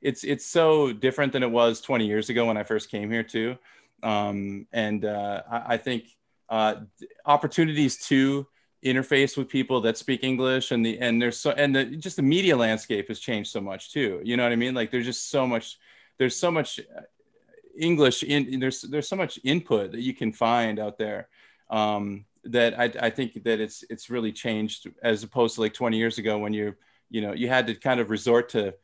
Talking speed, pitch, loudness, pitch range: 210 wpm, 120 Hz, -25 LUFS, 110-130 Hz